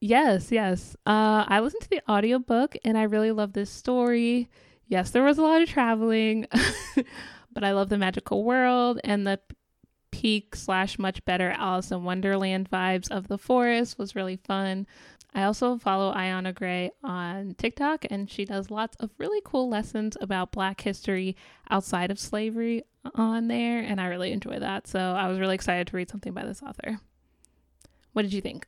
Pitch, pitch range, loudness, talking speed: 210 Hz, 190-235 Hz, -27 LUFS, 180 wpm